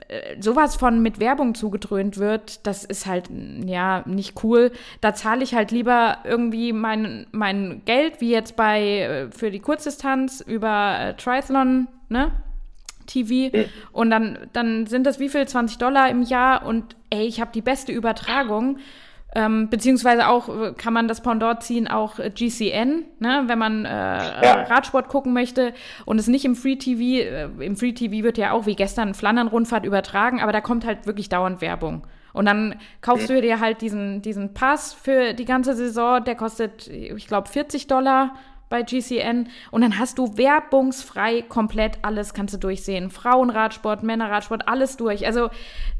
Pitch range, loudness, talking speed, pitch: 215-255 Hz, -21 LUFS, 165 wpm, 230 Hz